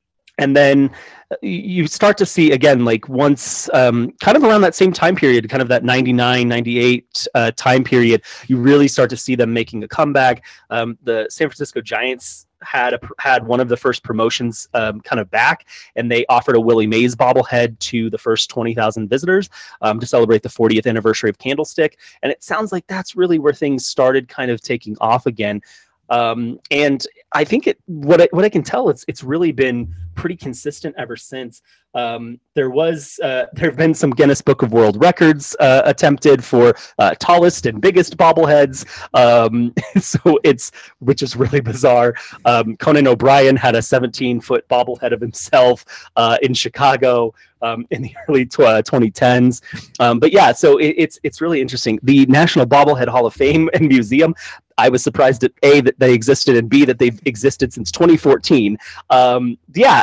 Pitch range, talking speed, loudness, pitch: 120-150 Hz, 185 wpm, -15 LUFS, 130 Hz